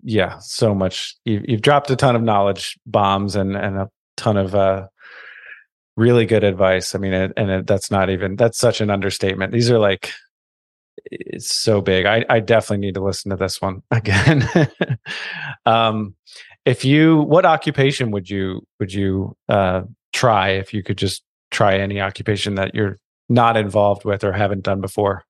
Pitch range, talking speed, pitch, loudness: 95-115 Hz, 170 wpm, 100 Hz, -18 LUFS